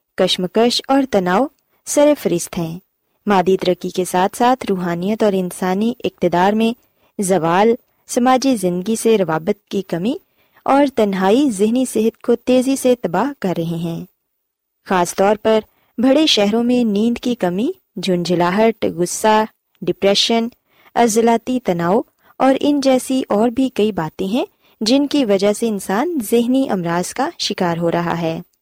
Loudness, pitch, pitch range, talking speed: -17 LUFS, 215 Hz, 185-250 Hz, 145 wpm